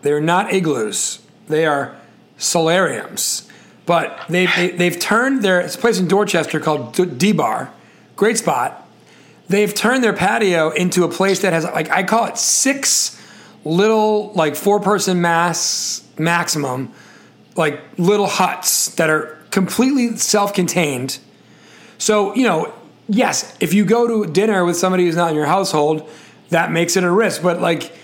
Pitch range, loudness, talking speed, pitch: 165-205 Hz, -17 LUFS, 160 wpm, 180 Hz